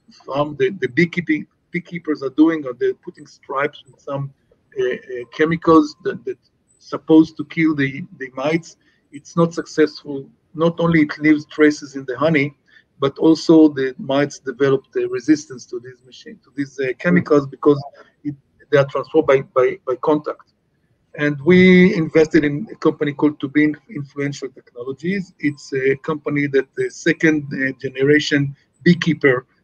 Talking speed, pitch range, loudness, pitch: 155 wpm, 140-165 Hz, -18 LUFS, 150 Hz